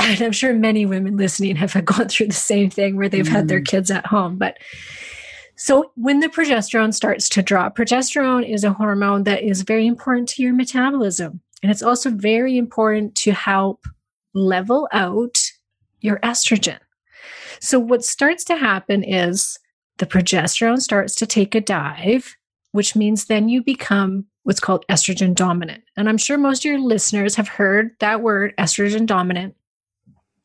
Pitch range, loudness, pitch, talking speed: 195-235 Hz, -18 LUFS, 210 Hz, 165 wpm